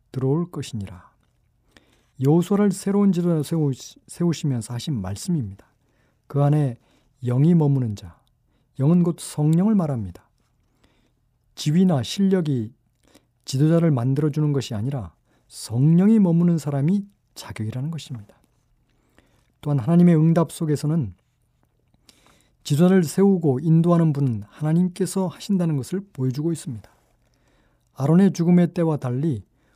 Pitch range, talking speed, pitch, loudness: 120-170 Hz, 280 characters per minute, 145 Hz, -21 LUFS